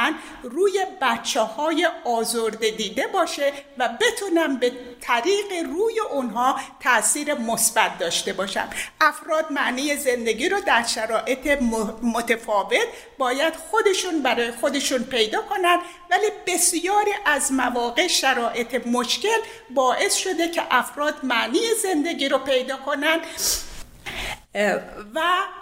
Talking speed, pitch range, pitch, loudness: 105 wpm, 245-355 Hz, 290 Hz, -22 LUFS